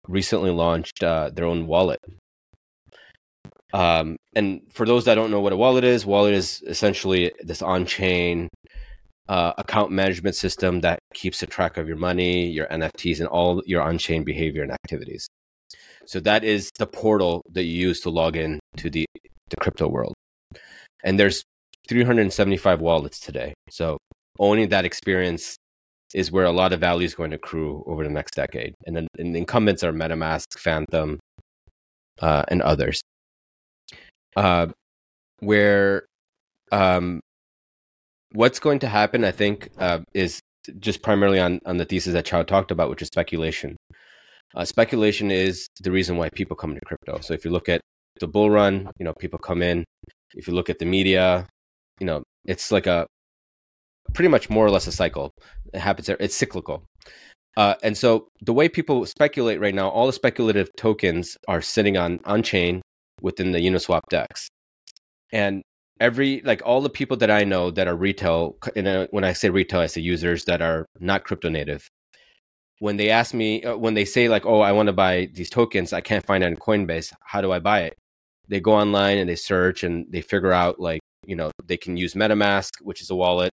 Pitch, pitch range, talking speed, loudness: 90 Hz, 85-100 Hz, 185 wpm, -22 LUFS